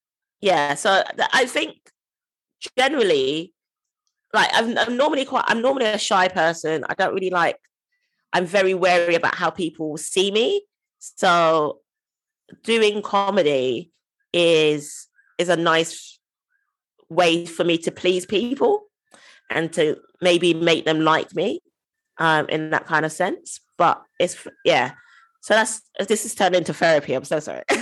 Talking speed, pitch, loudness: 140 wpm, 190 Hz, -20 LUFS